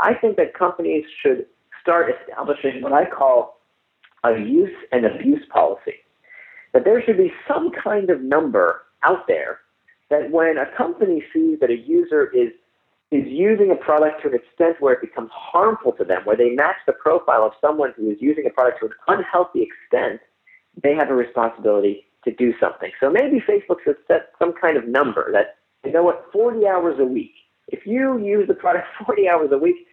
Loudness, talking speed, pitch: -19 LUFS, 190 wpm, 285 Hz